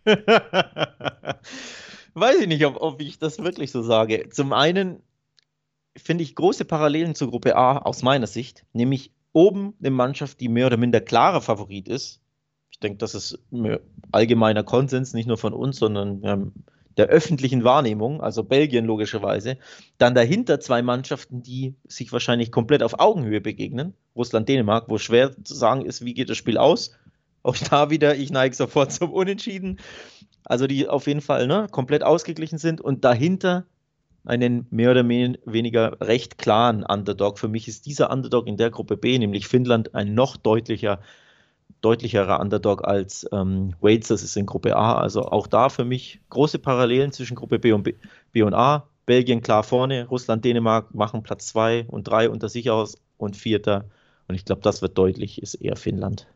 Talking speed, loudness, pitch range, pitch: 170 wpm, -22 LUFS, 110-145 Hz, 125 Hz